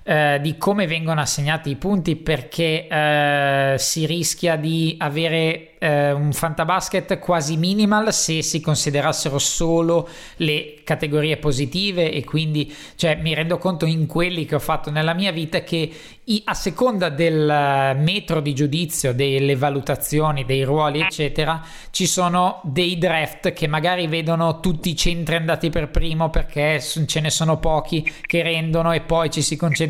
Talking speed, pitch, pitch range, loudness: 150 wpm, 160 Hz, 150-170 Hz, -20 LUFS